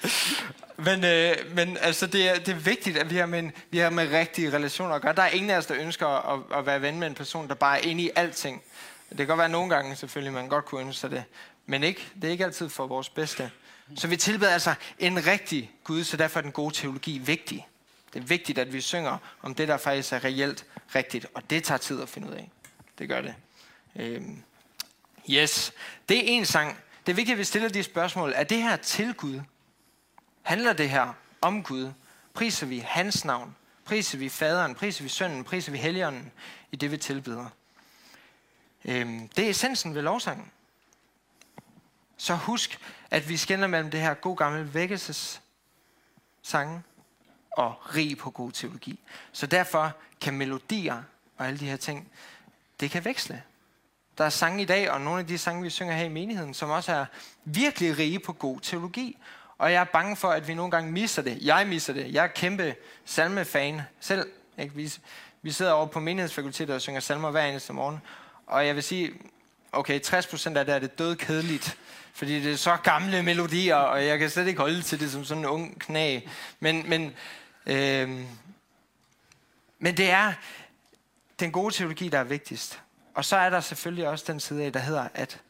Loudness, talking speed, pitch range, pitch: -27 LUFS, 200 wpm, 145-180 Hz, 160 Hz